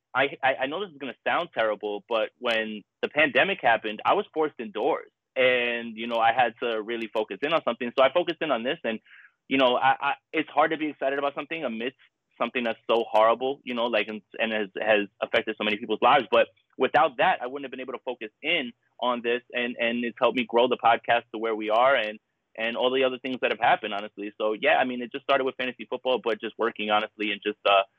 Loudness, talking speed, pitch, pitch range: -26 LUFS, 245 wpm, 120 Hz, 110-130 Hz